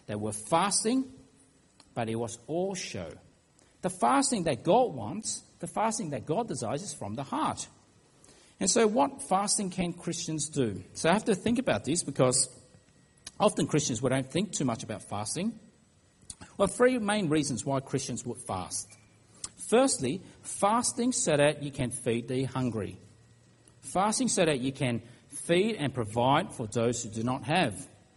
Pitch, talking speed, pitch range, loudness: 140 Hz, 165 wpm, 120-190 Hz, -29 LUFS